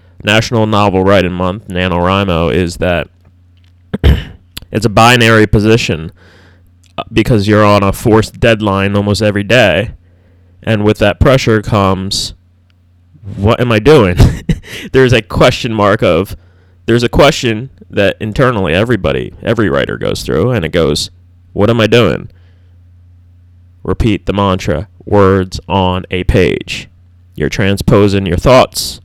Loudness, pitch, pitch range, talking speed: -11 LUFS, 95 Hz, 90-110 Hz, 130 wpm